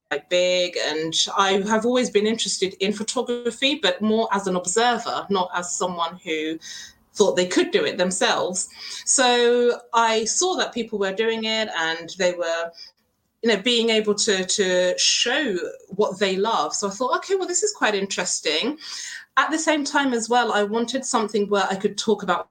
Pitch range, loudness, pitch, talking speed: 185-245 Hz, -21 LUFS, 215 Hz, 185 wpm